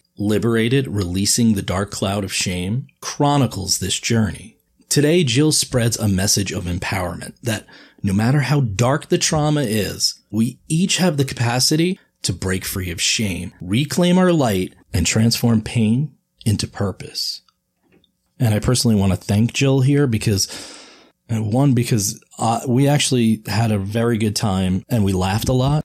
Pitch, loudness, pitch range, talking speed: 115 Hz, -19 LUFS, 100-135 Hz, 160 wpm